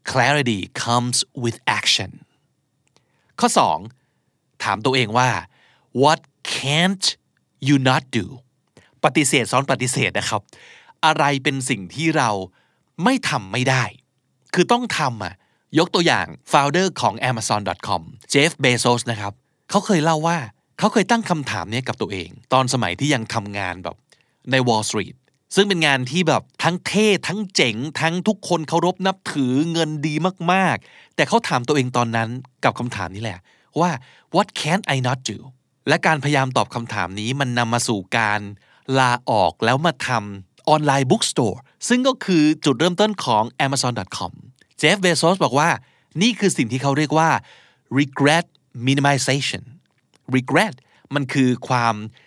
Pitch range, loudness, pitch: 120-160 Hz, -20 LUFS, 135 Hz